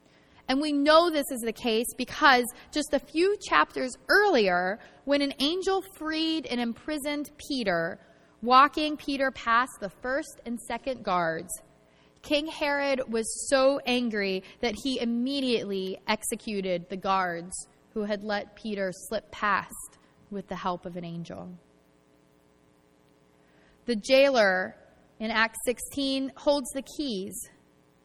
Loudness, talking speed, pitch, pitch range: -27 LUFS, 125 wpm, 235 Hz, 185-275 Hz